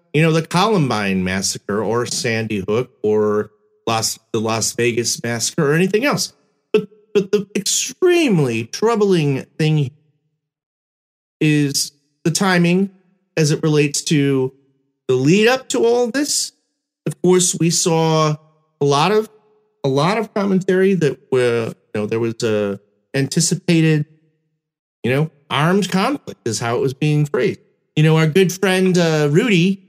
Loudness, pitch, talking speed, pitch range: -17 LUFS, 155 Hz, 145 wpm, 135-185 Hz